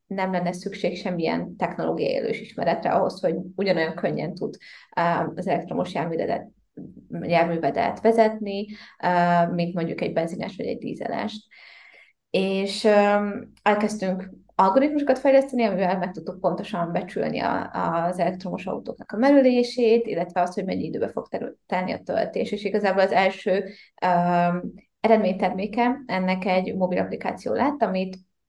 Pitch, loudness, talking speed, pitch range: 195 Hz, -24 LUFS, 120 wpm, 180-225 Hz